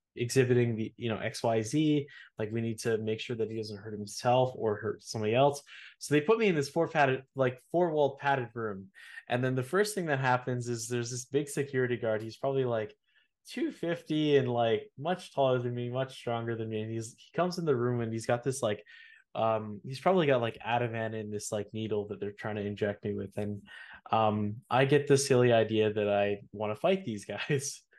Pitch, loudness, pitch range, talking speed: 120 Hz, -31 LUFS, 110-140 Hz, 220 wpm